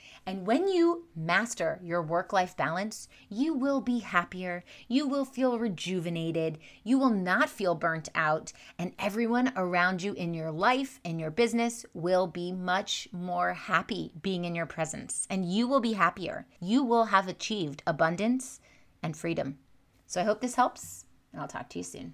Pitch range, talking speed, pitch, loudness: 170-235 Hz, 170 wpm, 185 Hz, -30 LUFS